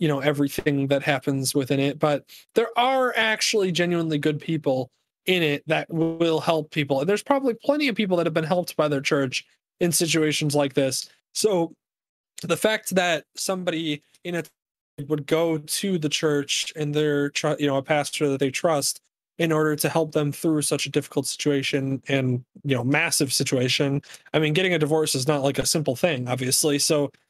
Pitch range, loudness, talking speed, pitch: 140-170 Hz, -23 LUFS, 195 wpm, 150 Hz